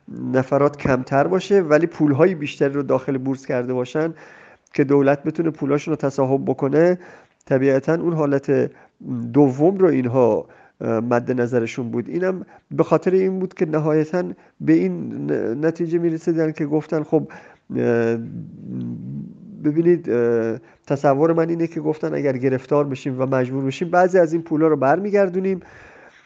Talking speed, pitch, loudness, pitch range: 135 wpm, 150 Hz, -20 LUFS, 135-170 Hz